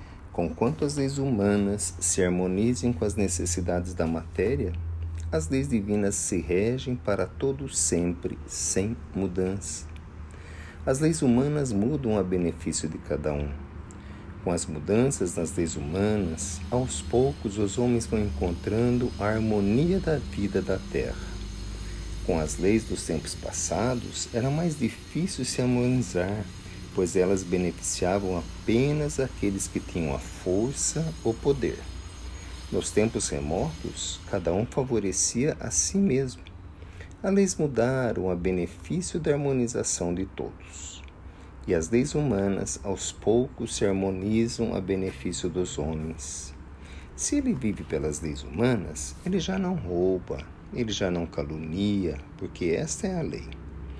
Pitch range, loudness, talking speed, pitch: 85-115 Hz, -28 LUFS, 130 wpm, 95 Hz